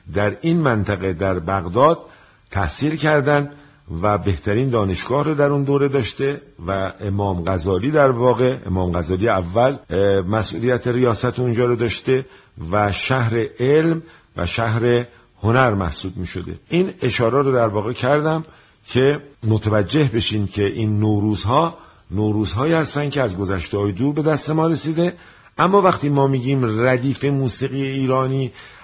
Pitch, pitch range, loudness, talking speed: 120 Hz, 100-140 Hz, -19 LUFS, 135 wpm